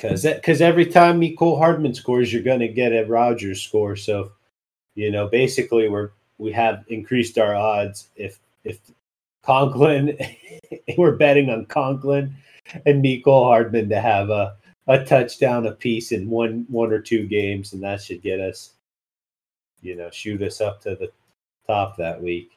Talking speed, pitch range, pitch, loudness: 165 wpm, 105-140 Hz, 115 Hz, -20 LUFS